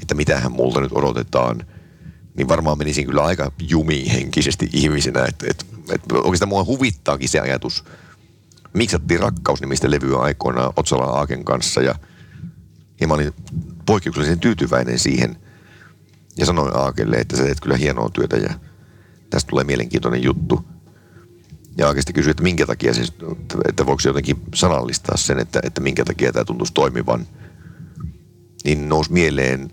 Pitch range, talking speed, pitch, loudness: 65-80 Hz, 145 wpm, 75 Hz, -19 LUFS